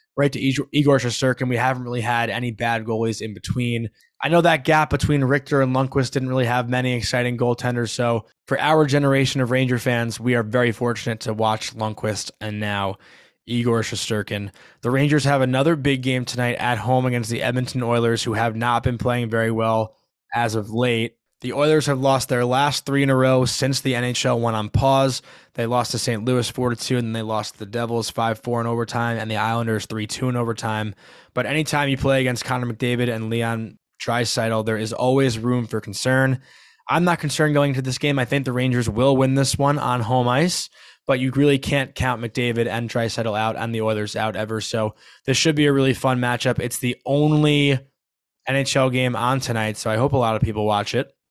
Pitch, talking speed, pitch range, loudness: 125 Hz, 210 wpm, 115-135 Hz, -21 LUFS